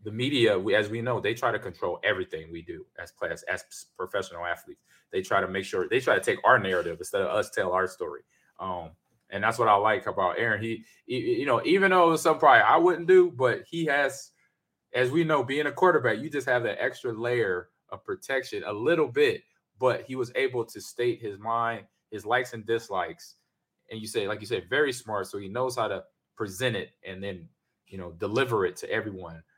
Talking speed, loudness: 225 wpm, -26 LUFS